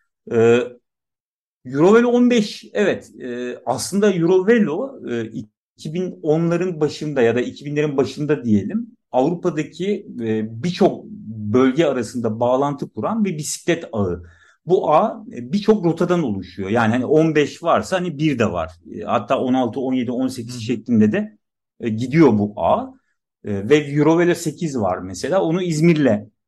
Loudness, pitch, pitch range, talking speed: -19 LUFS, 150 Hz, 120-185 Hz, 115 wpm